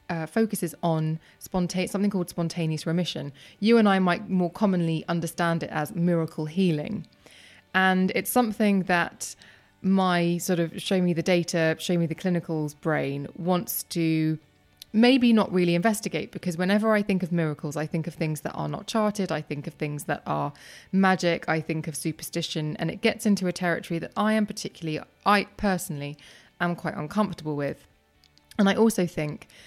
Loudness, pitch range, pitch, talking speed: -26 LUFS, 160-190 Hz, 175 Hz, 175 wpm